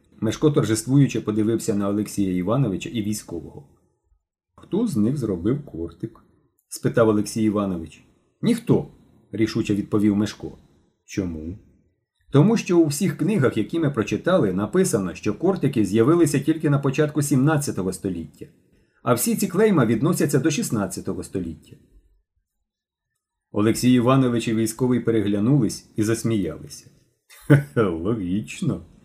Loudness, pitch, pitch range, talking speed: -22 LUFS, 110 Hz, 100-140 Hz, 110 wpm